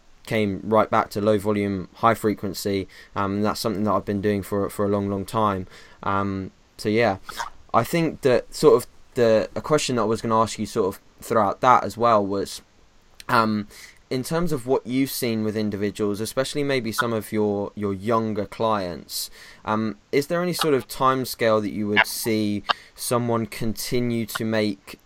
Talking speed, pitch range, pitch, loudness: 190 wpm, 100-115 Hz, 110 Hz, -23 LUFS